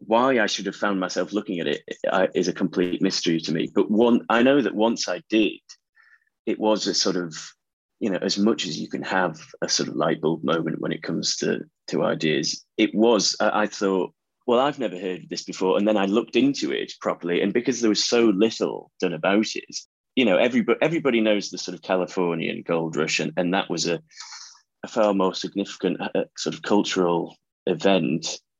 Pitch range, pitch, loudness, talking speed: 90-115 Hz, 100 Hz, -23 LUFS, 210 wpm